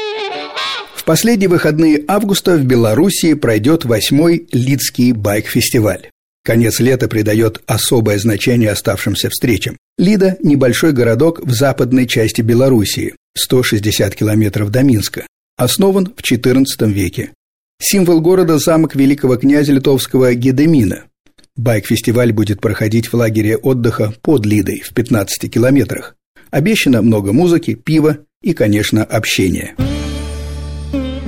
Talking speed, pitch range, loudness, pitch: 110 wpm, 110-150 Hz, -13 LUFS, 125 Hz